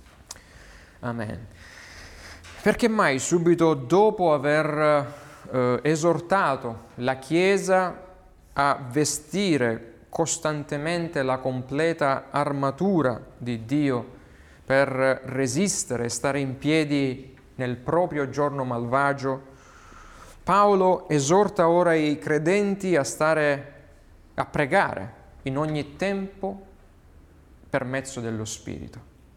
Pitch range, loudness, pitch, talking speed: 120-165 Hz, -24 LUFS, 140 Hz, 90 wpm